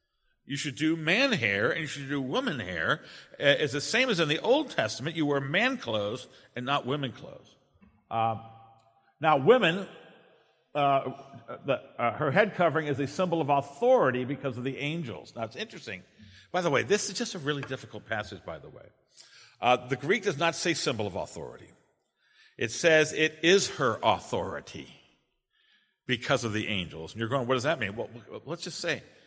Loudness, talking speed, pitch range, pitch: -28 LUFS, 185 wpm, 125-165 Hz, 145 Hz